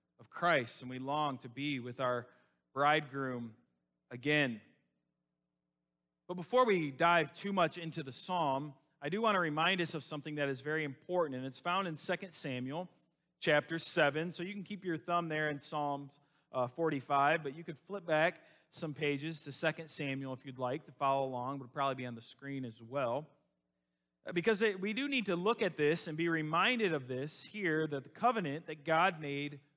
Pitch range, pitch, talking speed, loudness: 135-170 Hz, 150 Hz, 190 wpm, -35 LUFS